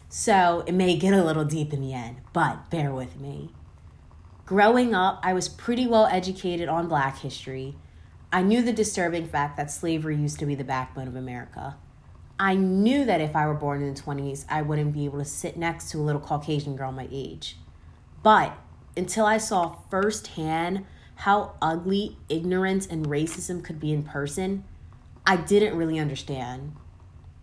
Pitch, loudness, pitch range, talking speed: 155 Hz, -25 LUFS, 135-185 Hz, 175 wpm